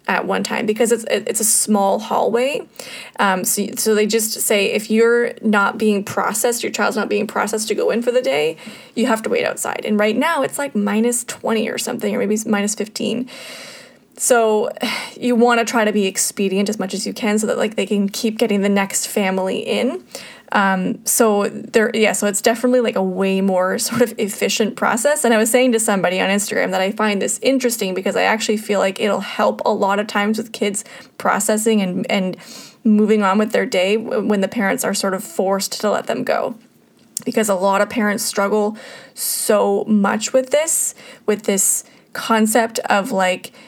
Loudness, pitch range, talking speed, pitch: -18 LUFS, 200-235 Hz, 205 wpm, 215 Hz